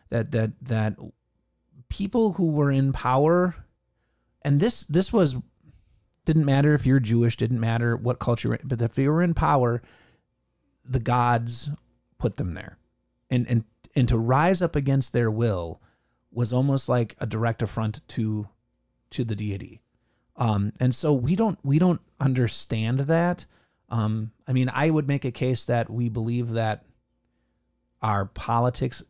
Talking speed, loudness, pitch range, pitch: 155 wpm, -24 LUFS, 110-140 Hz, 120 Hz